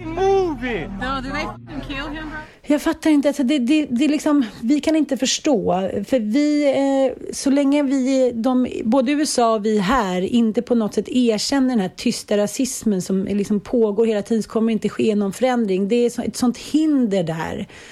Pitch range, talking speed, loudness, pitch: 220-285 Hz, 165 wpm, -19 LUFS, 250 Hz